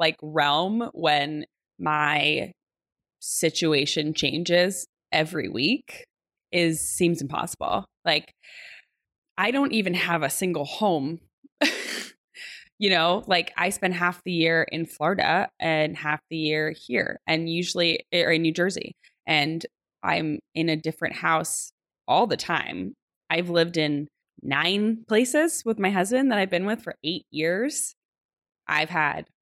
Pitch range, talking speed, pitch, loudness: 155-190 Hz, 135 wpm, 170 Hz, -24 LUFS